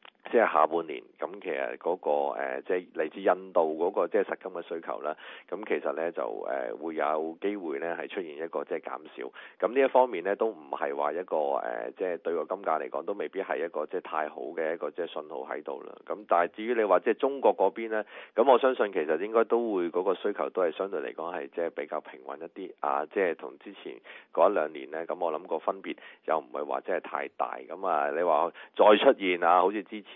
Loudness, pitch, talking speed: -29 LUFS, 135 Hz, 340 characters per minute